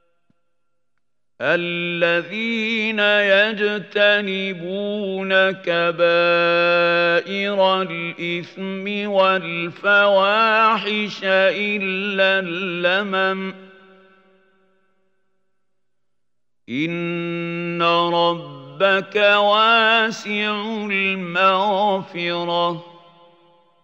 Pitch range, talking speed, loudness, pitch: 170-200 Hz, 30 wpm, -18 LUFS, 190 Hz